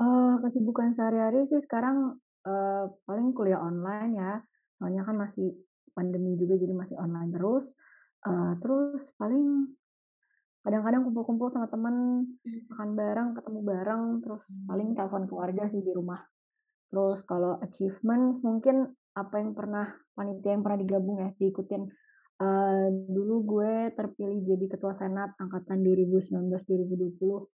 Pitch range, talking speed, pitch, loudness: 190-235 Hz, 130 wpm, 205 Hz, -30 LUFS